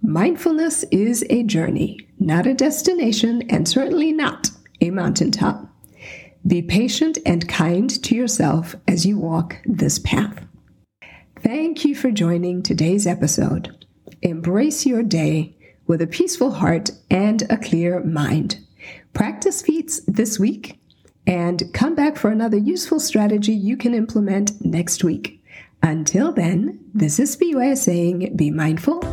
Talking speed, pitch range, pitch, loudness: 130 wpm, 175-260 Hz, 210 Hz, -19 LUFS